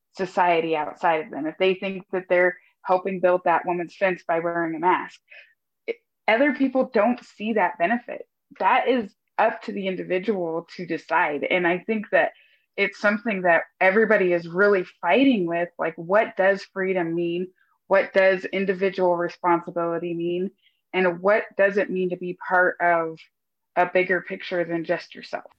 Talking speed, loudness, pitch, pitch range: 165 wpm, -23 LUFS, 185 Hz, 175-200 Hz